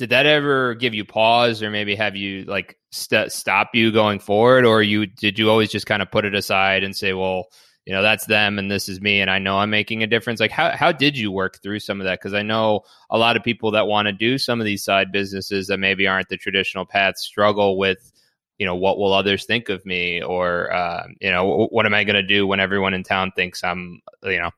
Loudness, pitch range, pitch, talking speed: -19 LUFS, 95-110 Hz, 105 Hz, 260 wpm